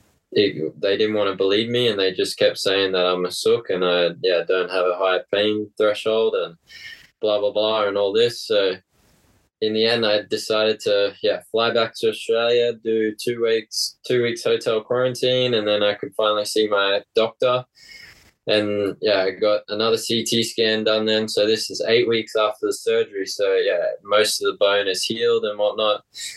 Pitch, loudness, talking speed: 115 Hz, -20 LUFS, 195 wpm